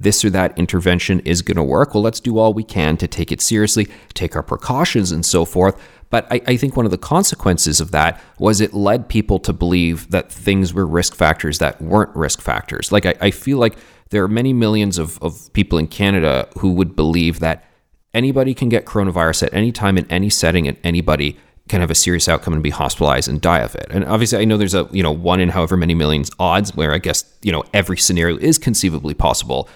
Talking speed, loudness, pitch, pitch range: 230 wpm, -16 LUFS, 95 Hz, 85-105 Hz